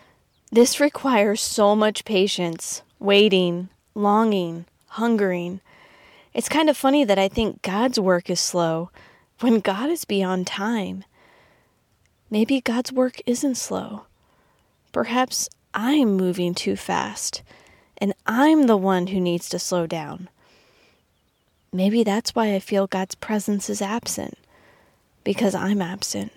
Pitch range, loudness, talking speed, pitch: 185-235 Hz, -22 LUFS, 125 wpm, 205 Hz